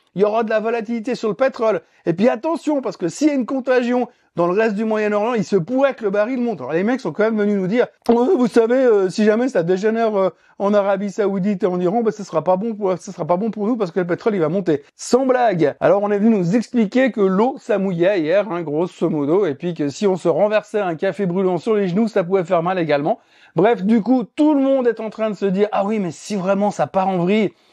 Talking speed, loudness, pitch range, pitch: 275 wpm, -19 LUFS, 190-235 Hz, 210 Hz